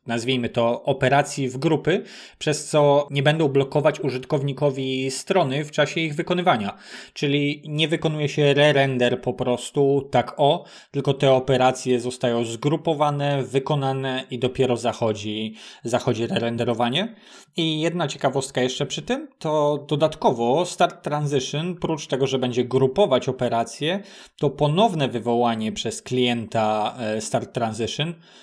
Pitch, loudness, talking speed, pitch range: 140 Hz, -22 LUFS, 130 wpm, 125-155 Hz